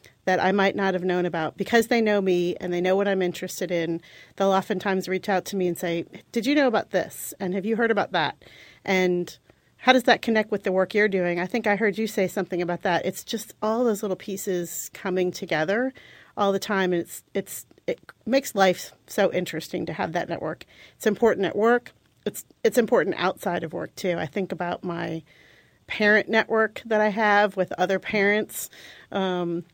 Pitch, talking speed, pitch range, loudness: 195 Hz, 210 wpm, 180-215 Hz, -24 LUFS